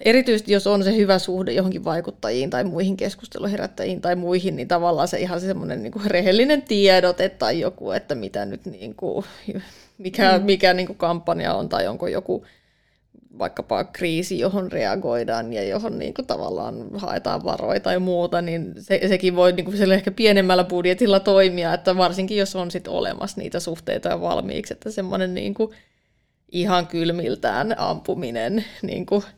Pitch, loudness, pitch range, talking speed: 185 Hz, -22 LUFS, 180-200 Hz, 160 wpm